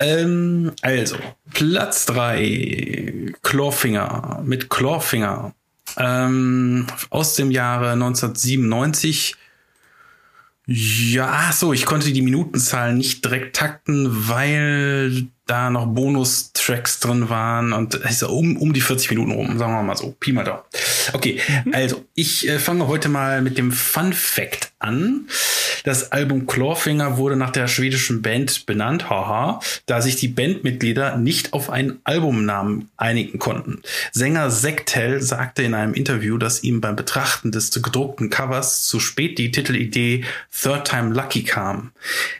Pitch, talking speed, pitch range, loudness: 130 Hz, 135 wpm, 120-145 Hz, -19 LUFS